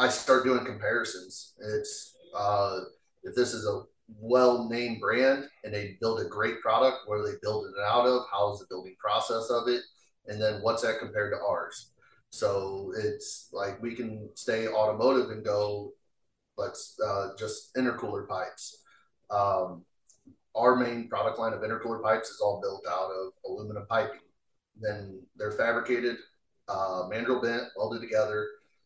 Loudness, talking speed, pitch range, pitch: -30 LUFS, 160 wpm, 105-125 Hz, 115 Hz